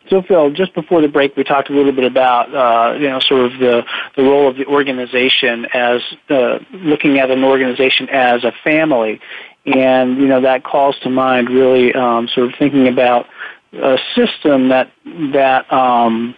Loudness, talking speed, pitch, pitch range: -13 LUFS, 185 wpm, 130 Hz, 125-140 Hz